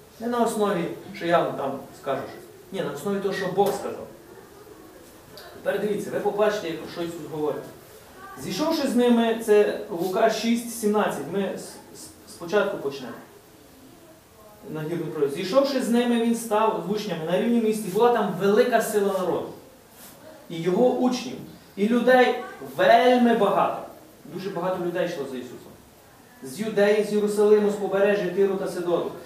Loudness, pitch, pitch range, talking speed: -24 LUFS, 205 Hz, 185-230 Hz, 145 wpm